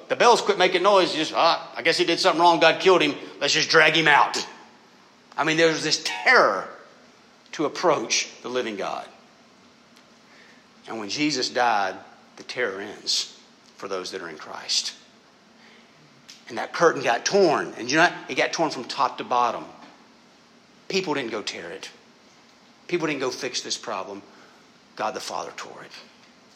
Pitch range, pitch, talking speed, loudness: 150-175 Hz, 160 Hz, 175 wpm, -22 LUFS